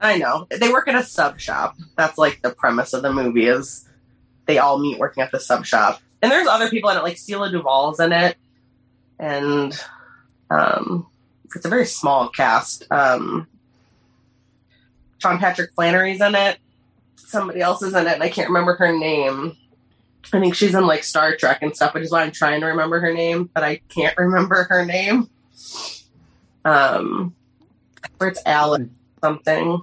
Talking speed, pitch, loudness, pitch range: 180 wpm, 160 Hz, -19 LUFS, 130-180 Hz